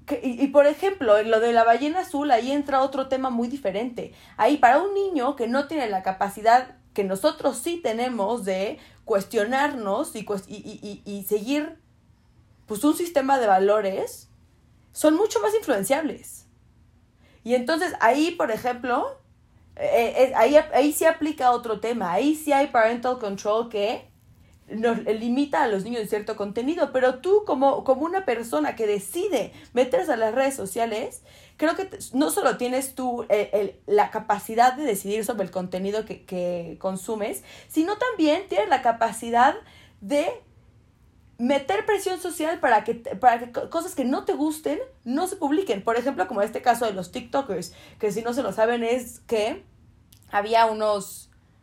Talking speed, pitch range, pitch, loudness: 165 wpm, 215-290 Hz, 245 Hz, -24 LUFS